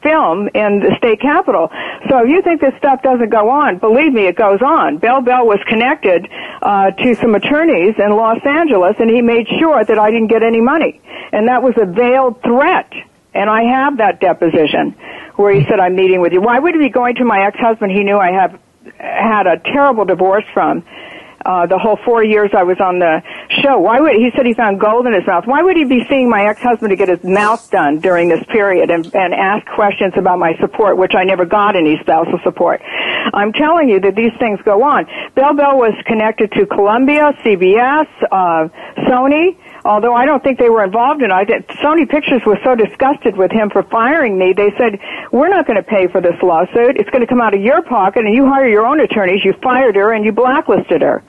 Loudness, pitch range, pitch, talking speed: -12 LUFS, 200-265 Hz, 225 Hz, 225 wpm